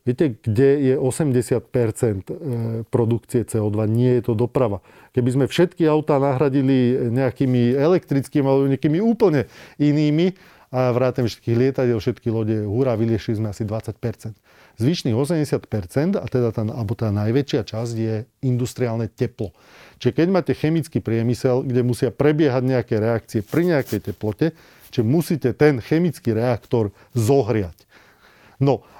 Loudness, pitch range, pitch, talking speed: -21 LUFS, 115-140 Hz, 125 Hz, 130 wpm